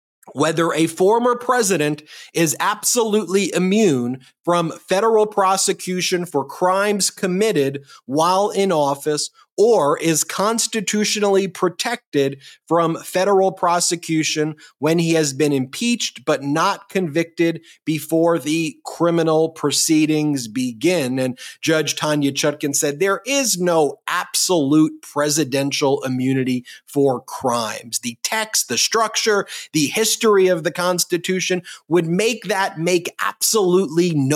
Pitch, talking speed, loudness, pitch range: 170 Hz, 110 wpm, -19 LUFS, 150-195 Hz